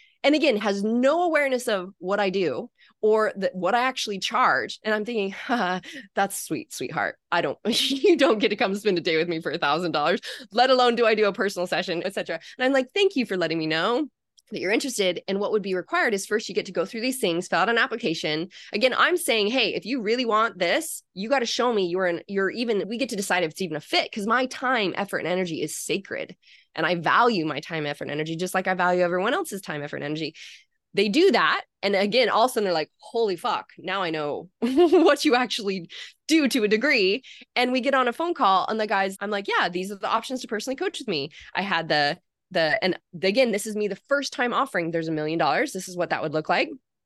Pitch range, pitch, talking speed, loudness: 180-250 Hz, 205 Hz, 255 wpm, -24 LUFS